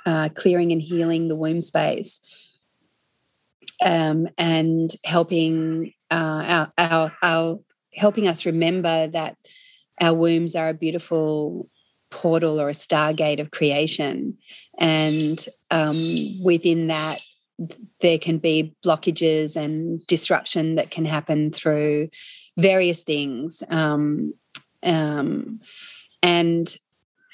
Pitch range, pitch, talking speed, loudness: 155-170 Hz, 165 Hz, 105 wpm, -21 LUFS